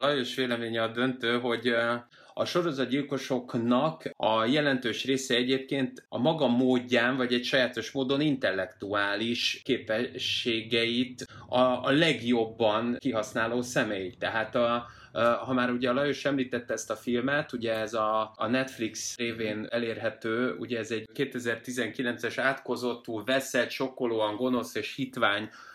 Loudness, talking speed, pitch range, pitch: -29 LUFS, 125 wpm, 115-130 Hz, 120 Hz